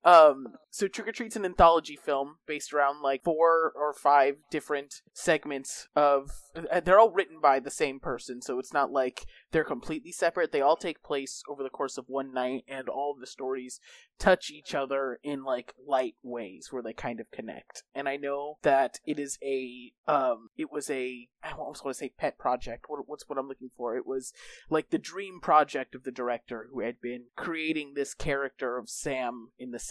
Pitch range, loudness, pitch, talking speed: 130-155 Hz, -29 LUFS, 140 Hz, 205 wpm